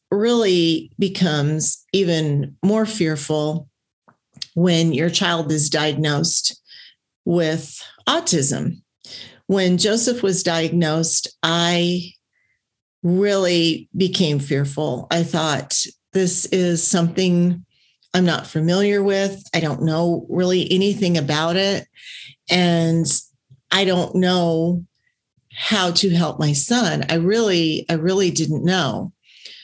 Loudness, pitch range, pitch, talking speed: -18 LUFS, 160-185 Hz, 170 Hz, 105 wpm